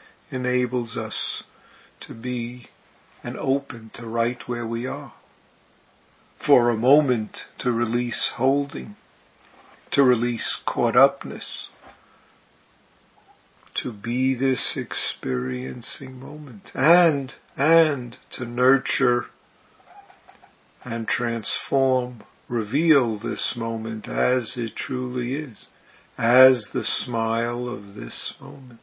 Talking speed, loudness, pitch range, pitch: 95 wpm, -23 LUFS, 115-135 Hz, 125 Hz